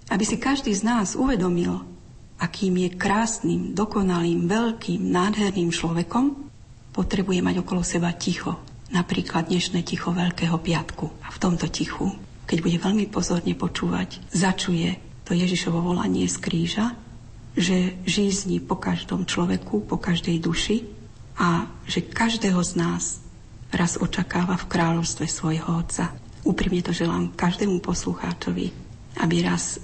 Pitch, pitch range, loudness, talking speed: 175 Hz, 165-195 Hz, -24 LUFS, 130 wpm